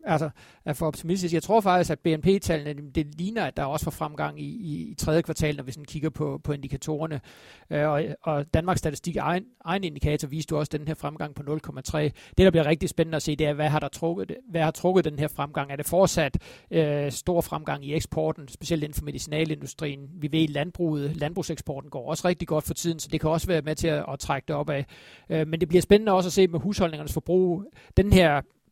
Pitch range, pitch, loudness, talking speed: 150-170 Hz, 155 Hz, -26 LUFS, 230 wpm